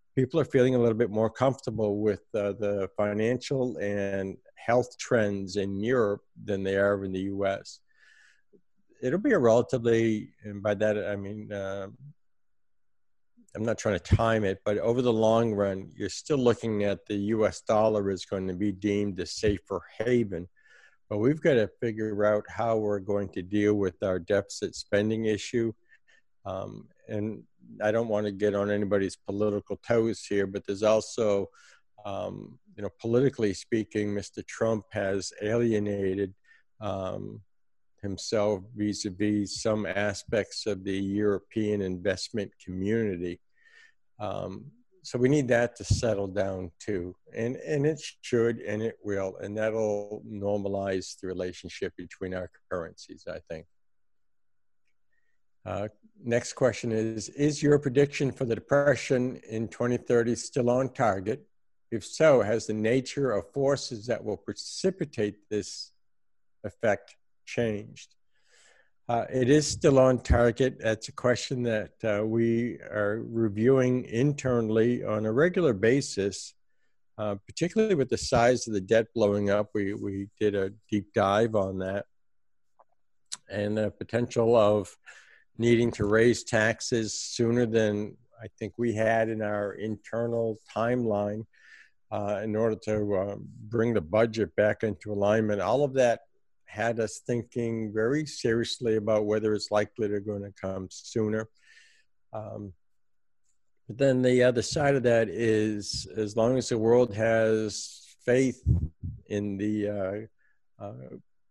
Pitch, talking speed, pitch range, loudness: 110 Hz, 145 wpm, 100-120 Hz, -28 LUFS